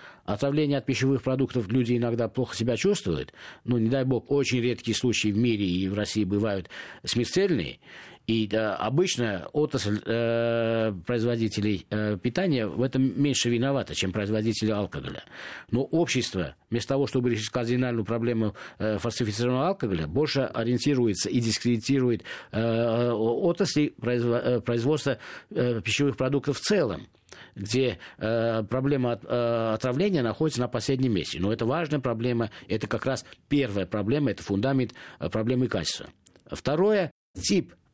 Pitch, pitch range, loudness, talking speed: 120 Hz, 110-130 Hz, -27 LUFS, 140 wpm